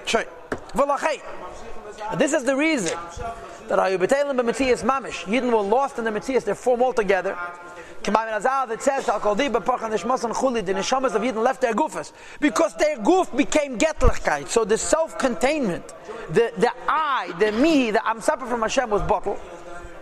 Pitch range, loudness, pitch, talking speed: 210-270 Hz, -22 LUFS, 235 Hz, 185 wpm